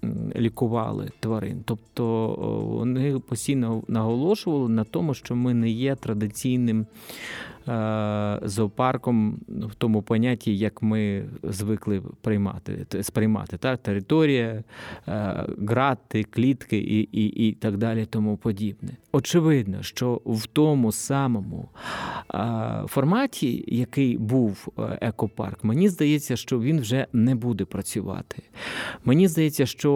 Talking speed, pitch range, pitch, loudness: 105 wpm, 110-135 Hz, 115 Hz, -25 LUFS